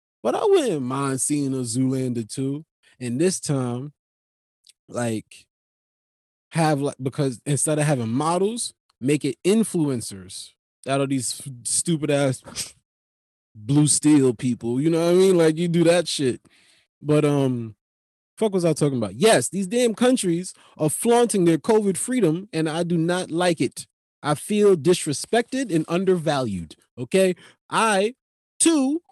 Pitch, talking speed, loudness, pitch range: 150 Hz, 140 wpm, -22 LUFS, 125-180 Hz